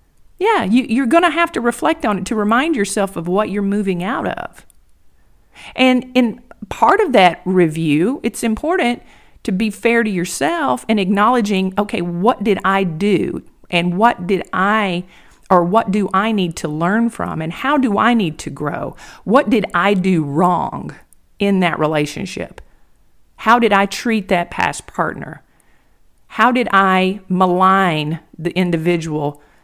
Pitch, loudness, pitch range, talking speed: 200 Hz, -16 LUFS, 180-235 Hz, 160 wpm